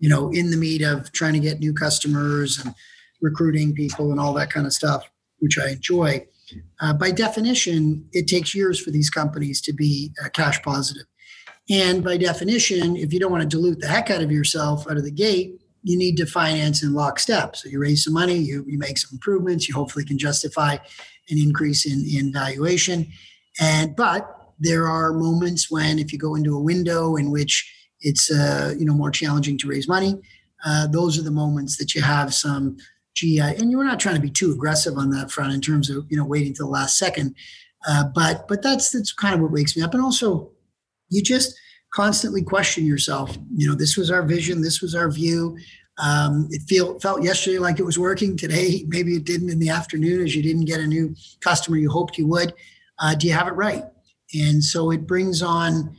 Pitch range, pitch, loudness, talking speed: 145-175 Hz, 160 Hz, -21 LUFS, 215 wpm